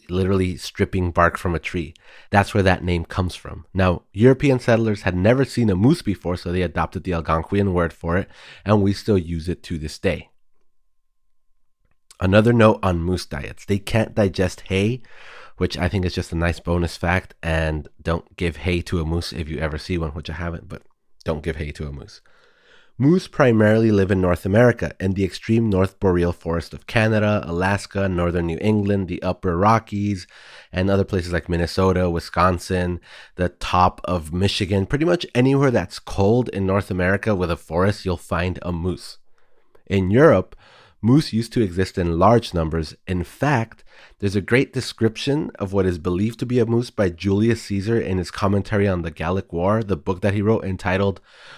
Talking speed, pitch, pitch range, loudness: 190 wpm, 95 Hz, 85-105 Hz, -21 LUFS